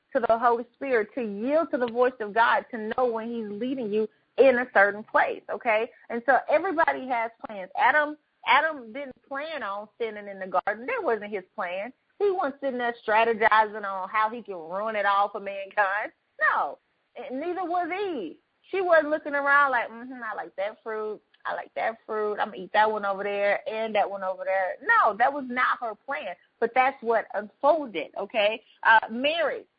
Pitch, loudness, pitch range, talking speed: 235 Hz, -26 LUFS, 210-285 Hz, 195 wpm